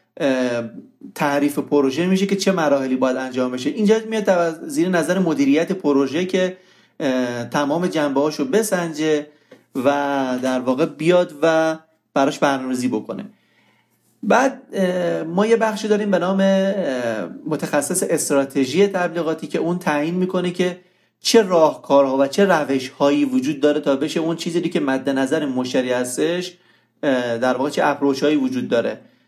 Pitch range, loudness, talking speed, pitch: 140-185 Hz, -19 LUFS, 125 wpm, 160 Hz